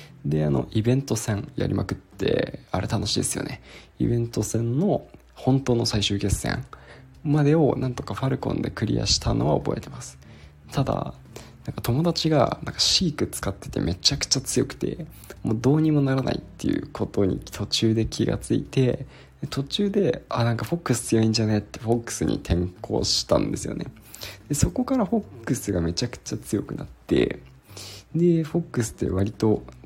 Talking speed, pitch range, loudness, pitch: 360 characters per minute, 105-140 Hz, -24 LUFS, 115 Hz